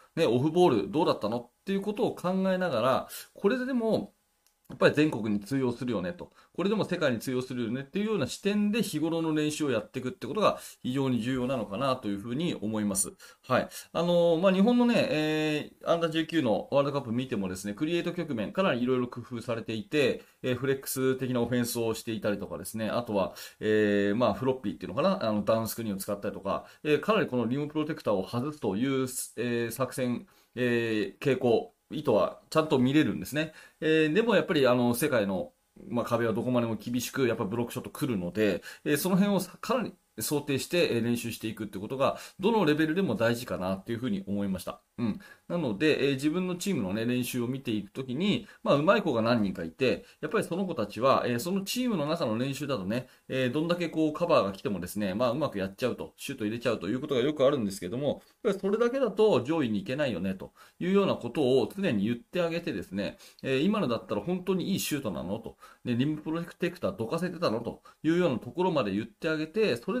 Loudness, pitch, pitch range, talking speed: -29 LUFS, 135 Hz, 115-170 Hz, 475 characters per minute